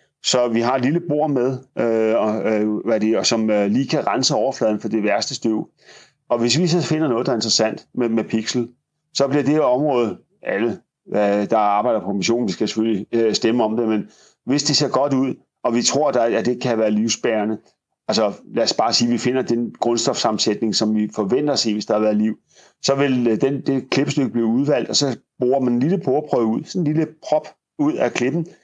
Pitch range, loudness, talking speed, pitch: 110-135 Hz, -19 LUFS, 225 wpm, 120 Hz